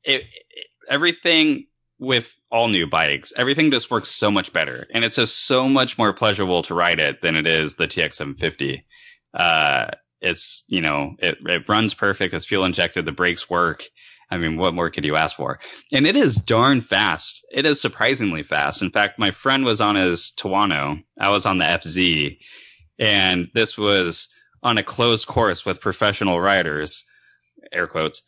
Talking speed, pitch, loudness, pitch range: 180 wpm, 105 Hz, -19 LUFS, 90-135 Hz